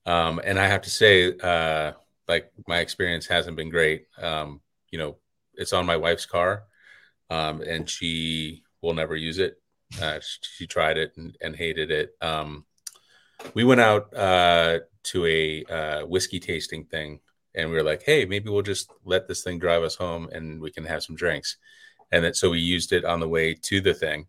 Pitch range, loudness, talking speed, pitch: 80-95 Hz, -24 LUFS, 195 wpm, 85 Hz